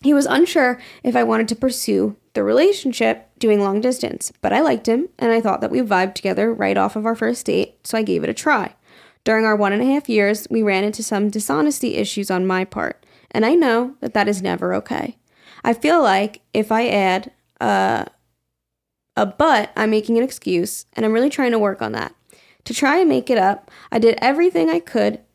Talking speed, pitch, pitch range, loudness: 220 wpm, 225 Hz, 200-255 Hz, -19 LUFS